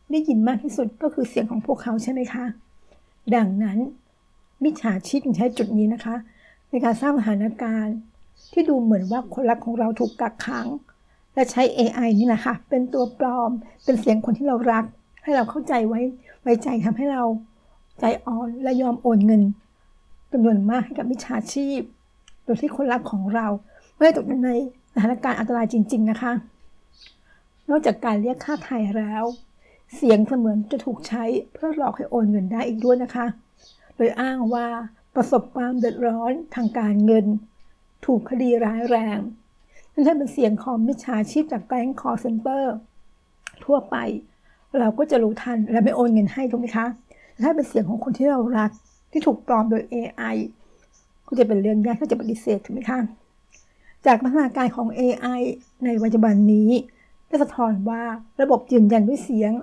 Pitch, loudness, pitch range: 240 Hz, -22 LUFS, 225-255 Hz